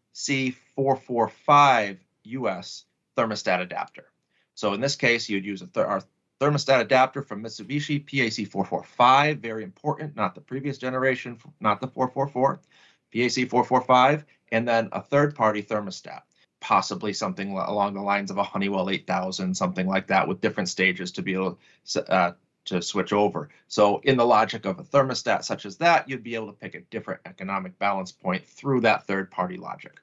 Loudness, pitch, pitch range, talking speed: -24 LUFS, 115 Hz, 100-135 Hz, 165 wpm